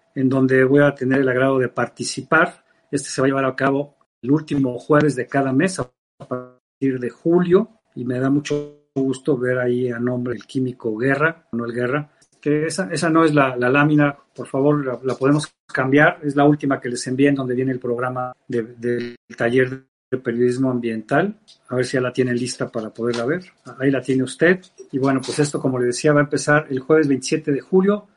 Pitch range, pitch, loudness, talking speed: 125-150 Hz, 135 Hz, -20 LUFS, 215 wpm